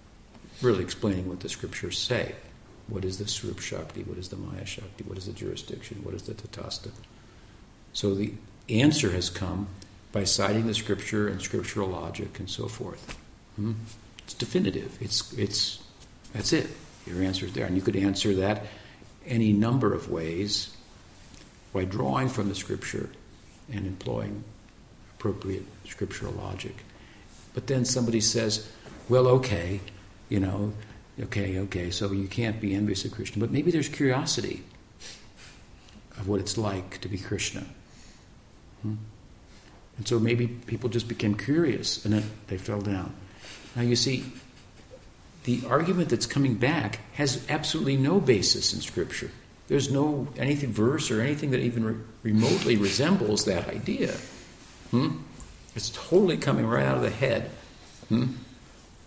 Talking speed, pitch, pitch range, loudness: 145 wpm, 105 Hz, 100-120 Hz, -28 LUFS